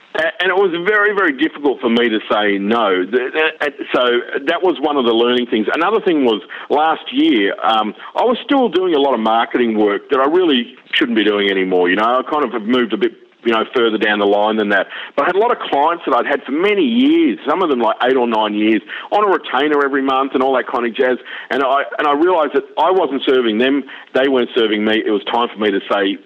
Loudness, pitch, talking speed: -15 LUFS, 130 Hz, 265 wpm